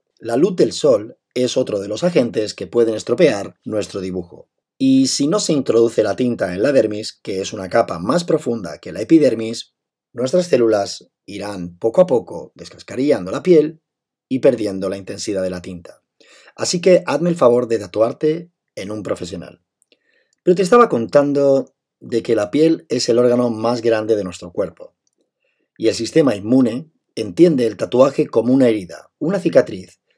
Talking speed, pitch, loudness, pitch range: 175 wpm, 120 Hz, -17 LUFS, 100-160 Hz